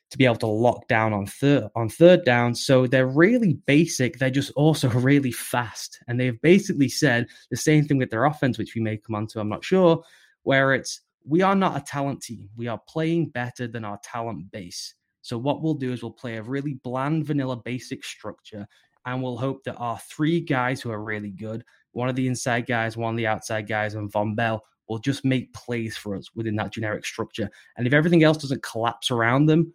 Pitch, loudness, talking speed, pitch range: 125 Hz, -23 LUFS, 225 wpm, 115-140 Hz